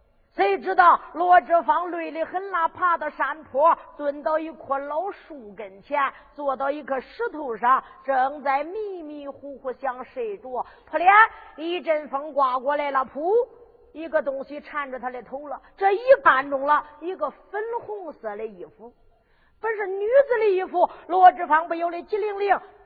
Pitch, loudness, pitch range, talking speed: 315 Hz, -23 LUFS, 275-370 Hz, 230 characters per minute